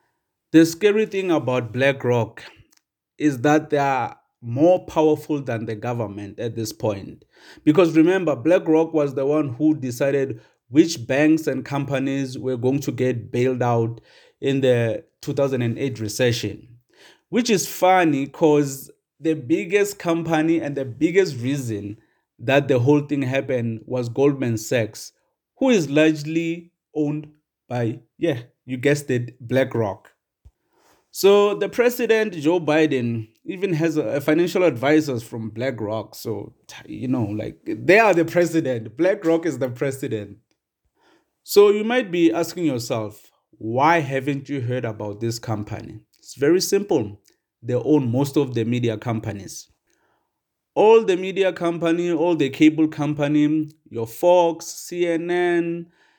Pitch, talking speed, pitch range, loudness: 145 Hz, 135 wpm, 120-165 Hz, -21 LUFS